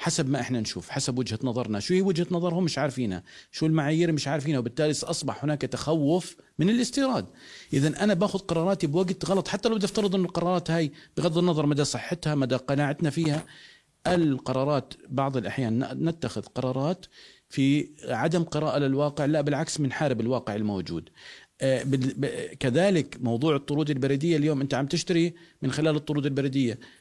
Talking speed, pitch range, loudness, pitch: 155 wpm, 130-170 Hz, -27 LUFS, 150 Hz